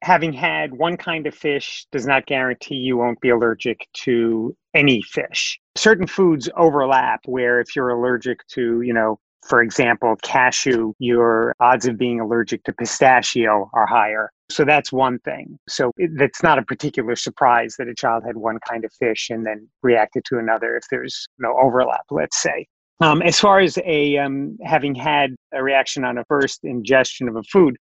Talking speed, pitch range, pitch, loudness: 185 wpm, 115-145 Hz, 125 Hz, -19 LUFS